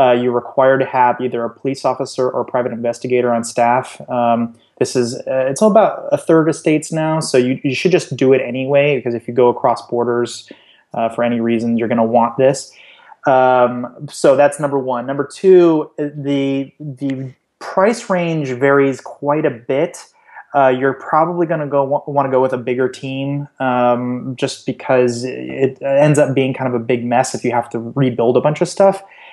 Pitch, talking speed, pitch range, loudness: 130 Hz, 195 wpm, 125-145 Hz, -16 LUFS